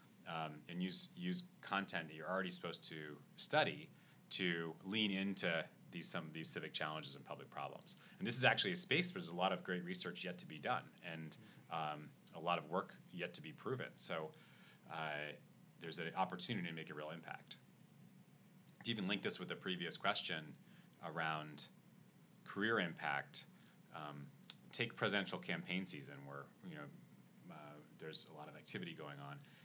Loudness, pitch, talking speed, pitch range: -43 LUFS, 85 Hz, 175 wpm, 75-95 Hz